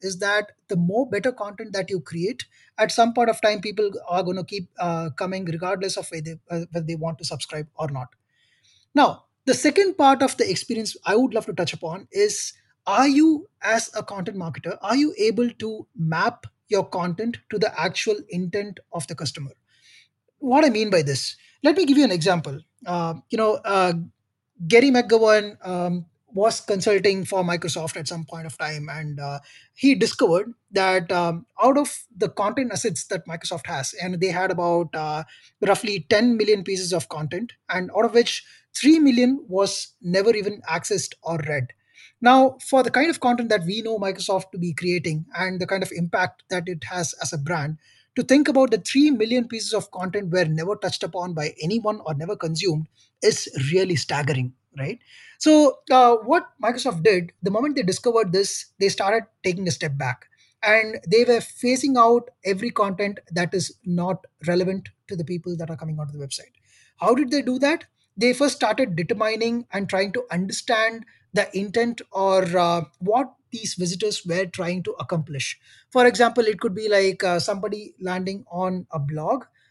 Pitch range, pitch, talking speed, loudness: 175-230 Hz, 195 Hz, 185 wpm, -22 LUFS